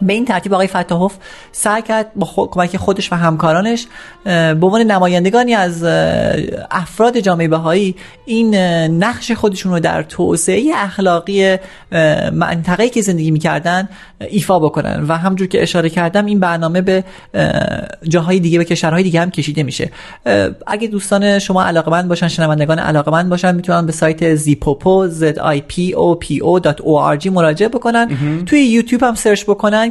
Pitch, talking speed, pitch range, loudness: 180 Hz, 140 wpm, 165-200 Hz, -14 LUFS